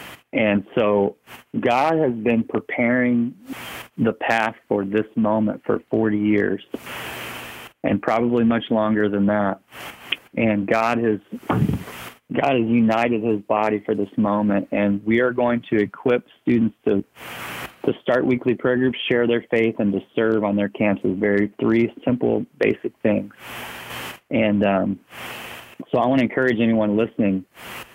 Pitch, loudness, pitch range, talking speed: 110 Hz, -21 LUFS, 100-115 Hz, 145 wpm